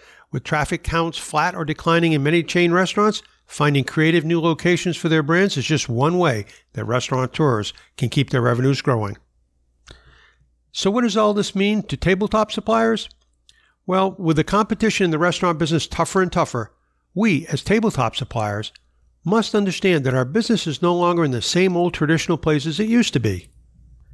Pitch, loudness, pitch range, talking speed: 165 Hz, -20 LUFS, 130-185 Hz, 175 wpm